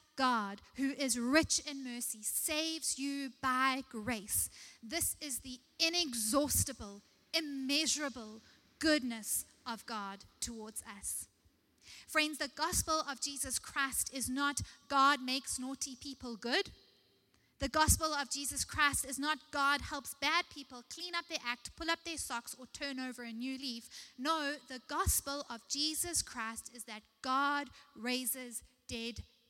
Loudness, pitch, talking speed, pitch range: -35 LUFS, 275 Hz, 140 wpm, 245-300 Hz